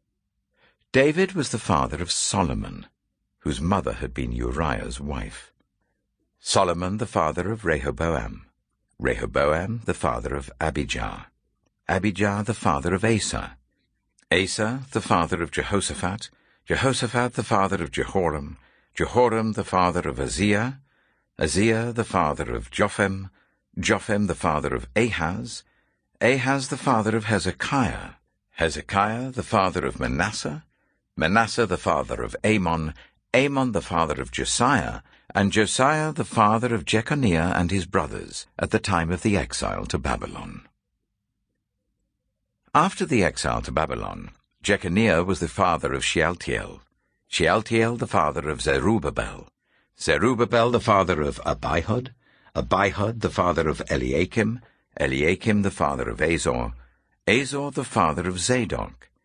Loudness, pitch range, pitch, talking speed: -24 LUFS, 85-115 Hz, 100 Hz, 125 wpm